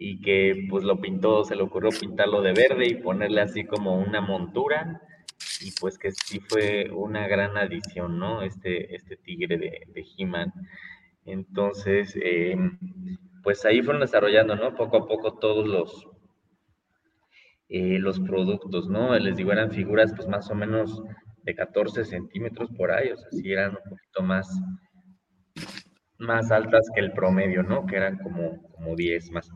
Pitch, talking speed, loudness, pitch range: 100 Hz, 160 wpm, -25 LUFS, 95-110 Hz